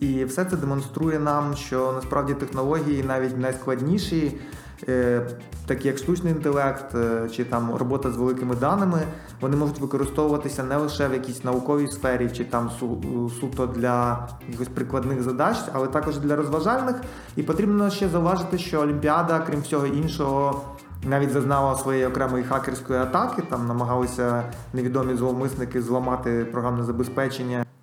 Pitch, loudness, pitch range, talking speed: 135 Hz, -25 LUFS, 125-145 Hz, 135 wpm